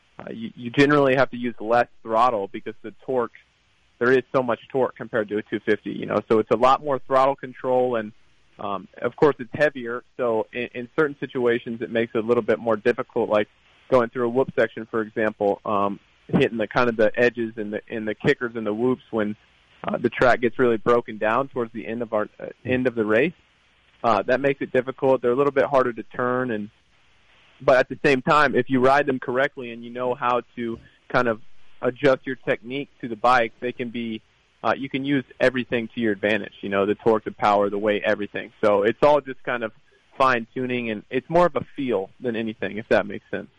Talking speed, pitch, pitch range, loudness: 230 wpm, 120 Hz, 110-130 Hz, -23 LUFS